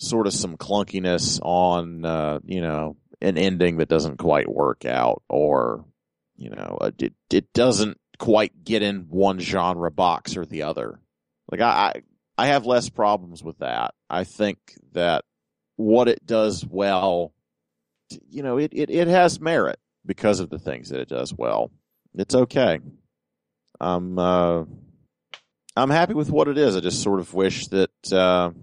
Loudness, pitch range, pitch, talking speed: -22 LUFS, 90-110 Hz, 95 Hz, 165 wpm